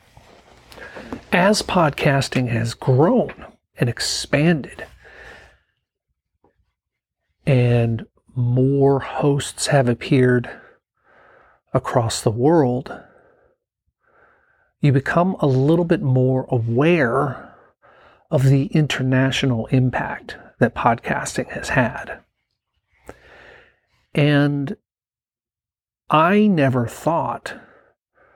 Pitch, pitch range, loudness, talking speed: 140 Hz, 130-165 Hz, -19 LUFS, 70 wpm